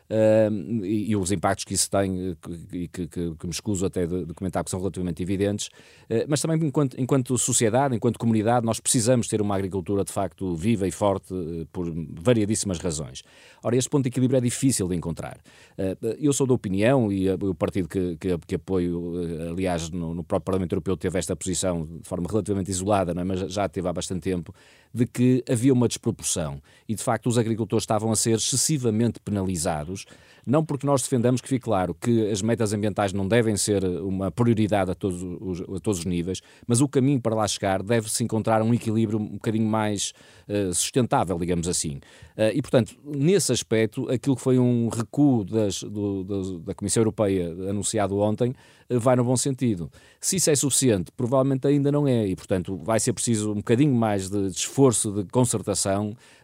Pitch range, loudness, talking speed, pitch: 95-120 Hz, -24 LUFS, 195 wpm, 105 Hz